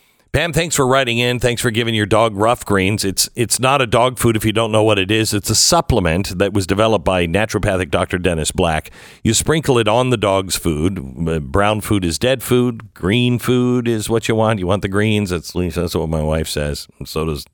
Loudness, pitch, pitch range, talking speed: -16 LUFS, 105 Hz, 90-120 Hz, 230 wpm